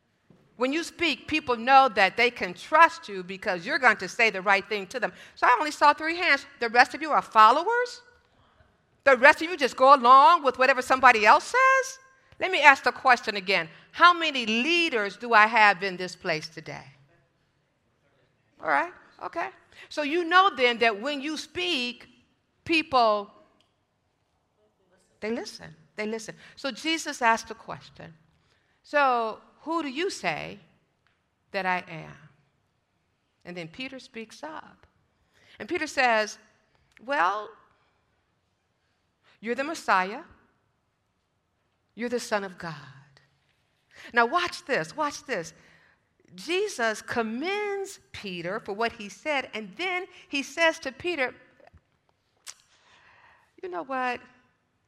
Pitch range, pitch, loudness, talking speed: 190-300 Hz, 245 Hz, -24 LUFS, 140 wpm